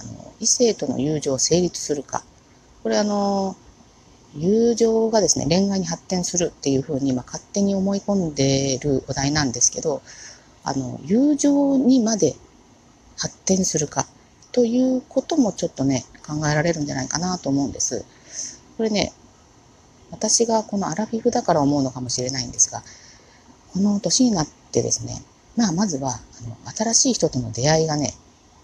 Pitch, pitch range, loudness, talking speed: 170 Hz, 135-220 Hz, -21 LUFS, 290 characters per minute